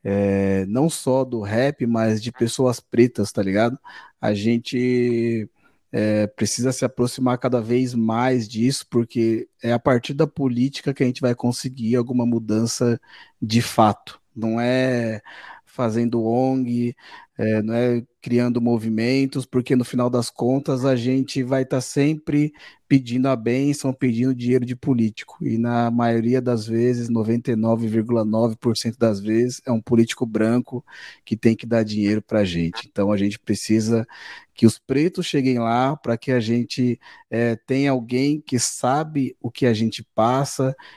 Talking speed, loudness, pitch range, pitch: 155 wpm, -21 LUFS, 115-130 Hz, 120 Hz